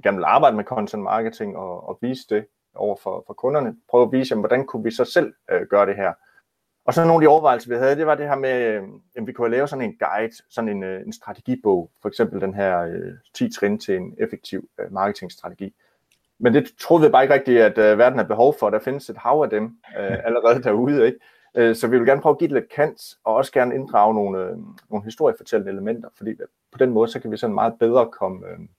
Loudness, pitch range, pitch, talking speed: -20 LUFS, 105-135 Hz, 120 Hz, 245 wpm